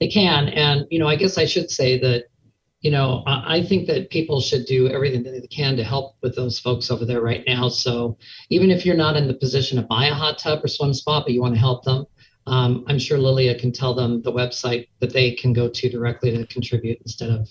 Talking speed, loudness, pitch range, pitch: 250 wpm, -20 LUFS, 120-145 Hz, 130 Hz